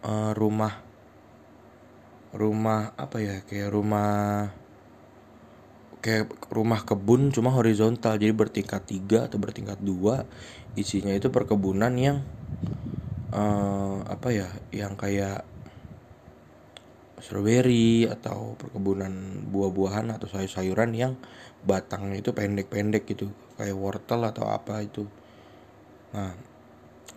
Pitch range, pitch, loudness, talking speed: 100-115 Hz, 105 Hz, -27 LUFS, 95 wpm